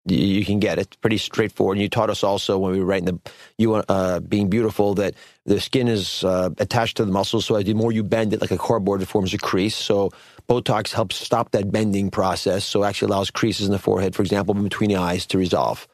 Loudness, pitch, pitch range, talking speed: -21 LUFS, 100 Hz, 95-110 Hz, 250 wpm